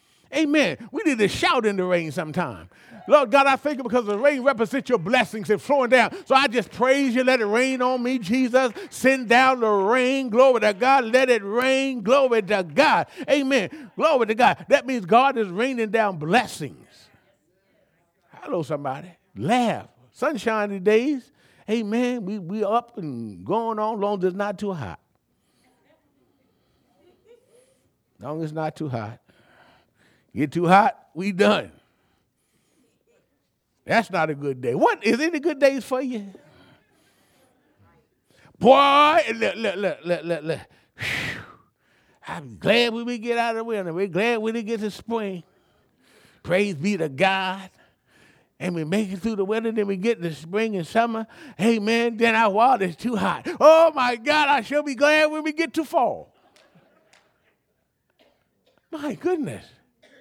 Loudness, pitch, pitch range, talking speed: -21 LUFS, 230 Hz, 195-265 Hz, 160 wpm